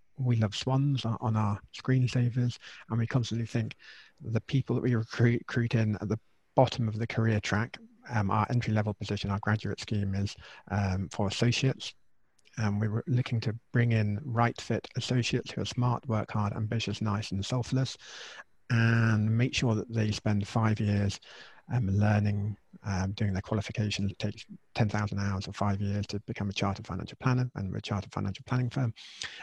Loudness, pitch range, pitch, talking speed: -30 LUFS, 105-120 Hz, 110 Hz, 175 wpm